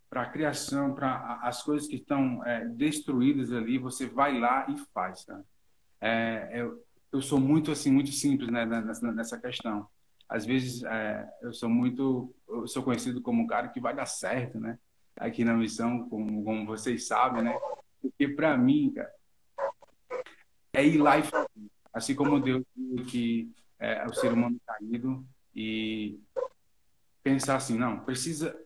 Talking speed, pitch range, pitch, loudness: 155 wpm, 115-140 Hz, 125 Hz, -30 LUFS